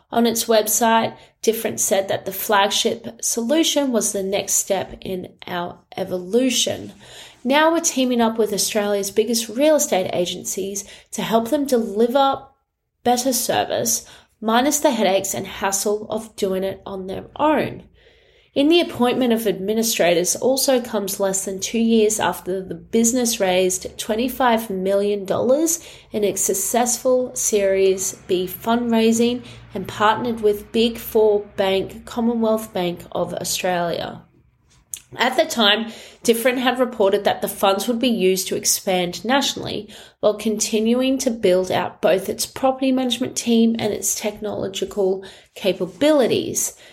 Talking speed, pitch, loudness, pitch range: 135 wpm, 215 Hz, -20 LUFS, 195-245 Hz